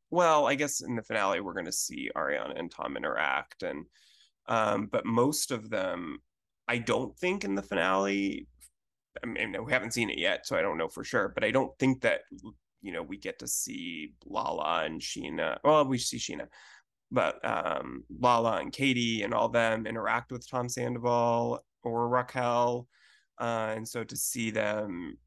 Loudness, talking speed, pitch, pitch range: -30 LUFS, 185 wpm, 120 Hz, 115-145 Hz